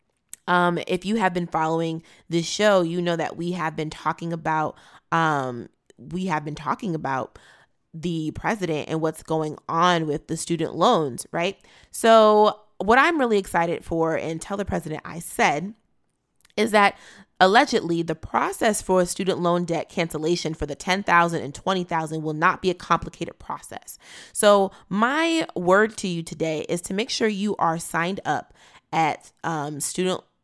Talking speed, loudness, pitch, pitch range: 170 wpm, -23 LUFS, 170 Hz, 160-195 Hz